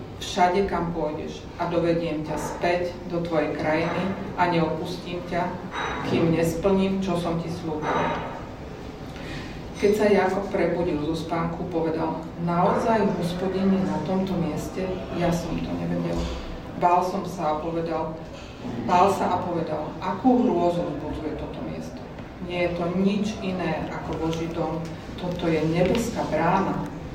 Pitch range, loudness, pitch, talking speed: 160-180 Hz, -25 LUFS, 175 Hz, 135 wpm